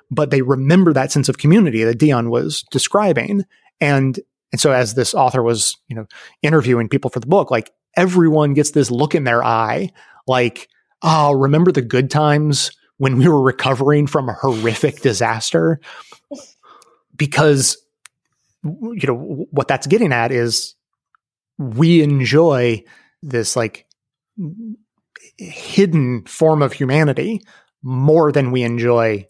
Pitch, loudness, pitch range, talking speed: 140 Hz, -16 LUFS, 125-160 Hz, 135 wpm